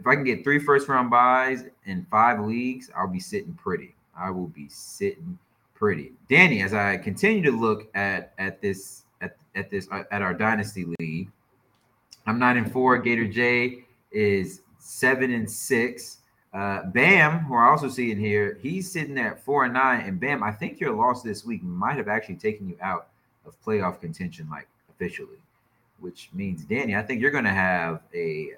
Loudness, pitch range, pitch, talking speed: -24 LUFS, 110-160 Hz, 125 Hz, 185 wpm